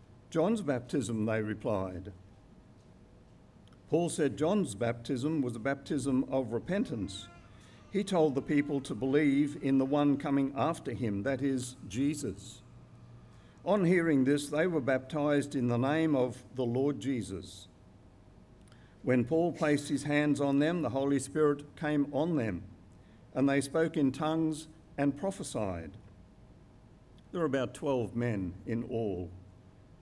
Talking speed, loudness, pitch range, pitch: 135 wpm, -32 LUFS, 110-150 Hz, 135 Hz